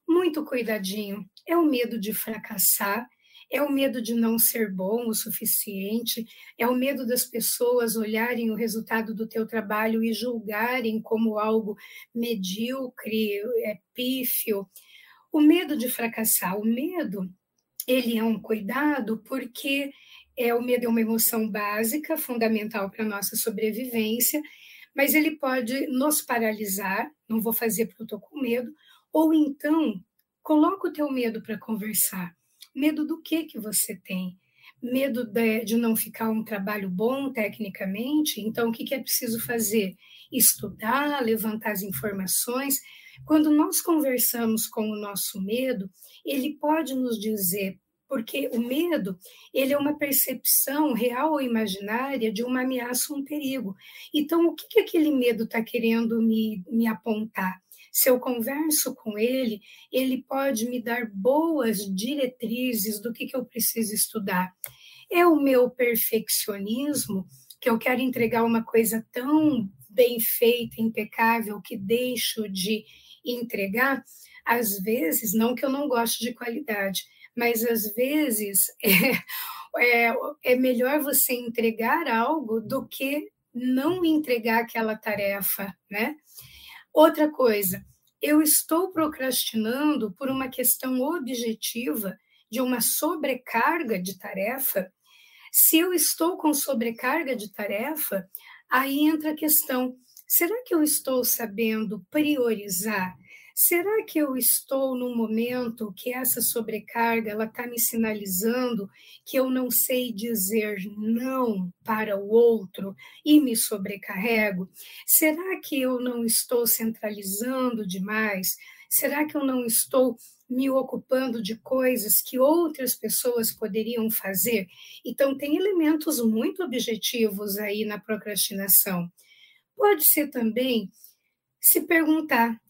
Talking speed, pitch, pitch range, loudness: 130 wpm, 235 Hz, 220-270 Hz, -25 LUFS